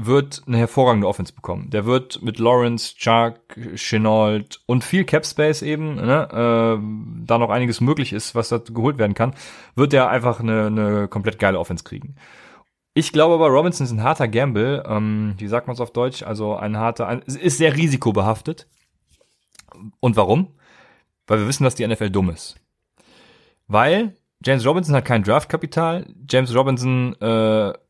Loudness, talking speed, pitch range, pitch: -19 LUFS, 170 wpm, 110-140 Hz, 120 Hz